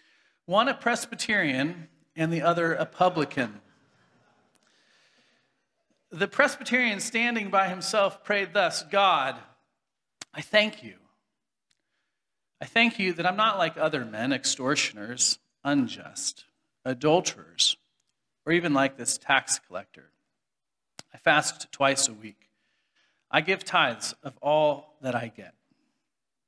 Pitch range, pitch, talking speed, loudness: 150-215 Hz, 180 Hz, 115 wpm, -26 LUFS